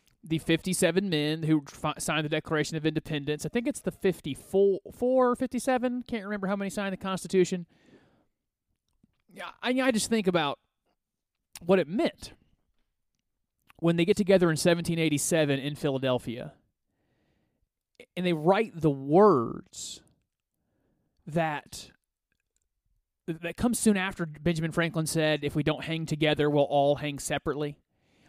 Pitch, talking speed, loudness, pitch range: 165 Hz, 135 wpm, -27 LUFS, 150-195 Hz